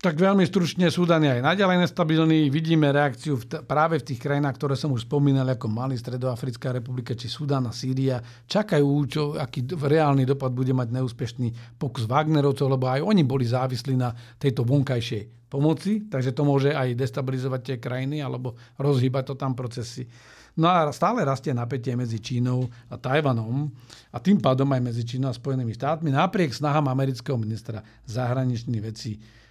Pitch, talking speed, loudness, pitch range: 135 Hz, 170 wpm, -24 LUFS, 125-150 Hz